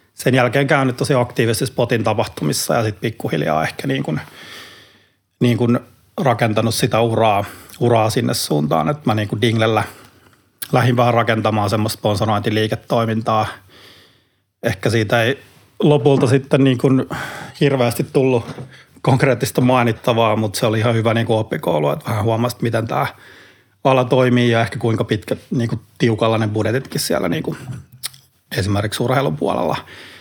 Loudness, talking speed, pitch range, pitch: -18 LUFS, 135 wpm, 110-130 Hz, 120 Hz